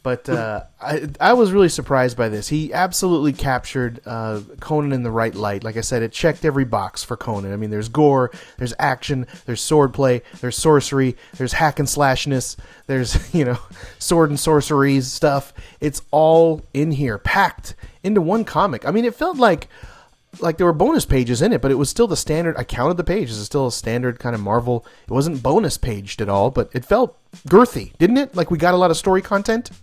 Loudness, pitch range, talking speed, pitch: -19 LUFS, 120-165 Hz, 210 wpm, 135 Hz